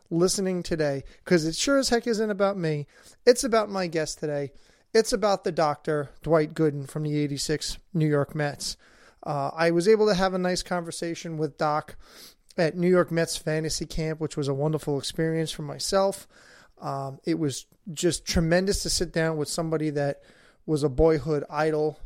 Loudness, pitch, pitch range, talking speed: -26 LUFS, 160 Hz, 150-180 Hz, 180 wpm